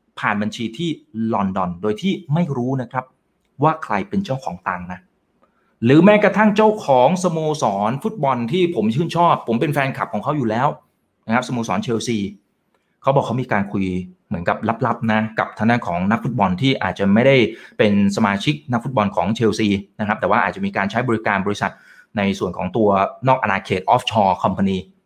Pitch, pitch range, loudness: 115 Hz, 100-150 Hz, -19 LUFS